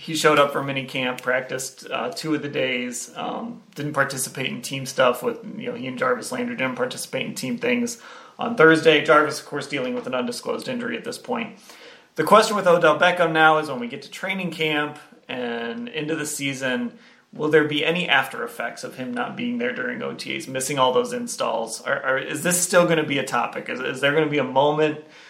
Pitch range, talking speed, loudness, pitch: 140-235 Hz, 225 wpm, -22 LUFS, 155 Hz